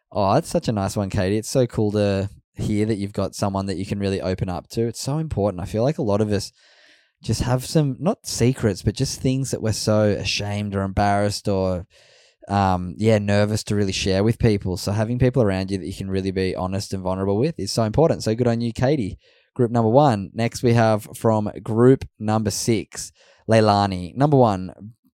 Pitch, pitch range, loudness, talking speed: 105 Hz, 95-120 Hz, -21 LUFS, 215 wpm